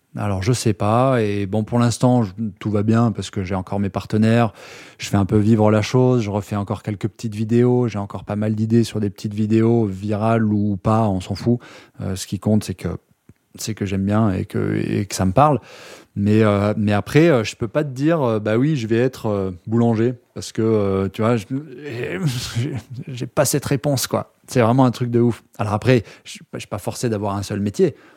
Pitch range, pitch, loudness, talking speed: 105-120 Hz, 110 Hz, -20 LUFS, 230 wpm